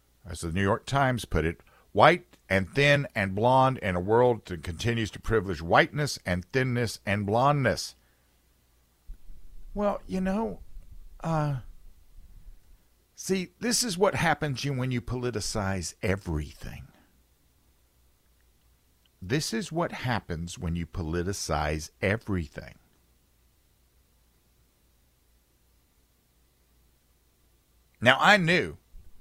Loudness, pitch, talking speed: -27 LUFS, 90 Hz, 100 wpm